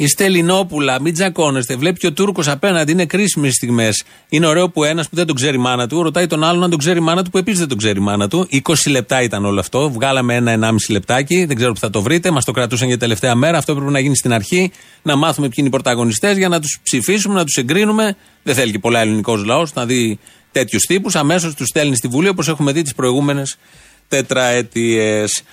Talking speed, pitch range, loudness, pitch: 230 wpm, 125-170 Hz, -15 LUFS, 140 Hz